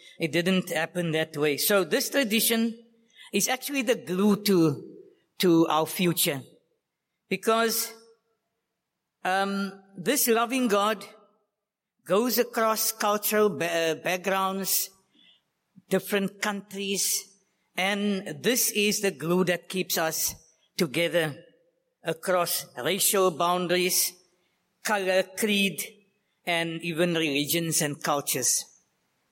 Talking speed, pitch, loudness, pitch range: 95 wpm, 190 Hz, -26 LUFS, 175-215 Hz